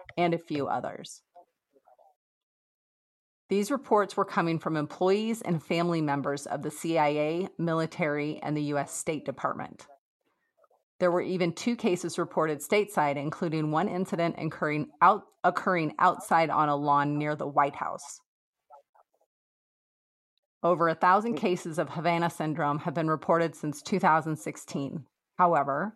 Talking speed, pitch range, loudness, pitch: 130 wpm, 150-180 Hz, -28 LUFS, 165 Hz